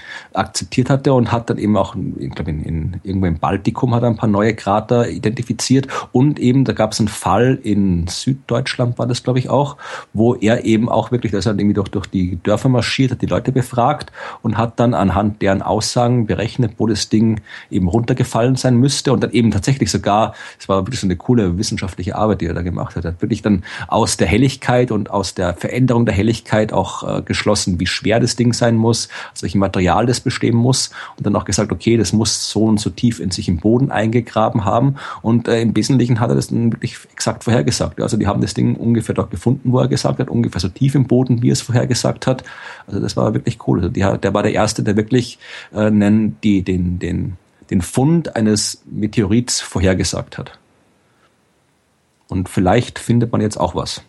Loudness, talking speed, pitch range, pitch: -17 LUFS, 215 wpm, 100-120 Hz, 110 Hz